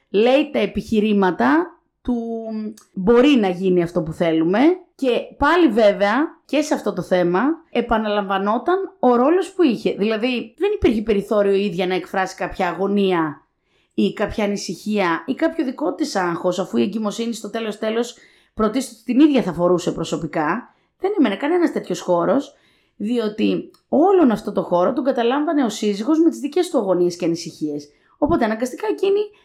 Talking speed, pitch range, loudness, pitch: 155 wpm, 190-290 Hz, -19 LUFS, 220 Hz